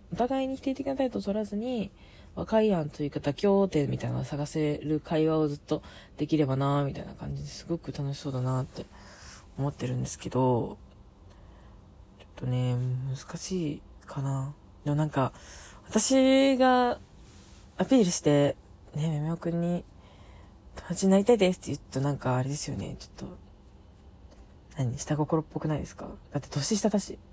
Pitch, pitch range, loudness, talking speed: 145 Hz, 125-180 Hz, -29 LUFS, 325 characters per minute